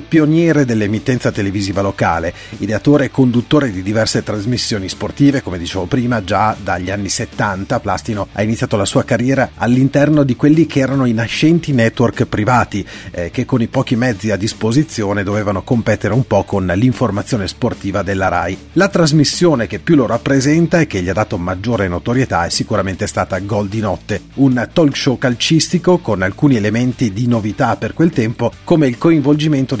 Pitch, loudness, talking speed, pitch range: 115 Hz, -15 LUFS, 170 wpm, 100-135 Hz